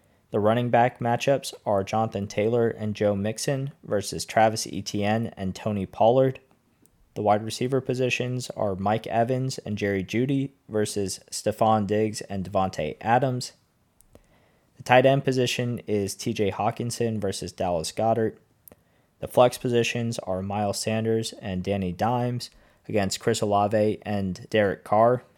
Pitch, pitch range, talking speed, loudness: 110 Hz, 100-120 Hz, 135 wpm, -25 LUFS